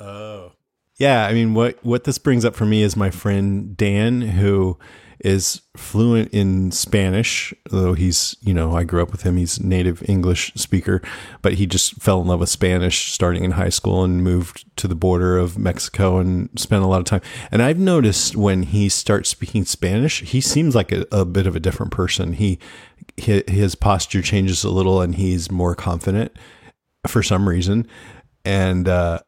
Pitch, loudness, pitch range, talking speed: 95 Hz, -19 LUFS, 90-110 Hz, 185 wpm